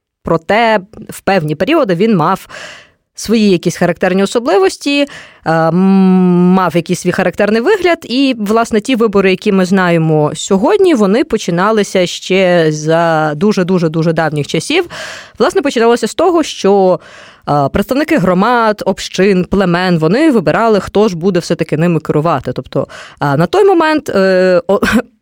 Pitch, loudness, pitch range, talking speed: 190 Hz, -11 LUFS, 175-225 Hz, 125 wpm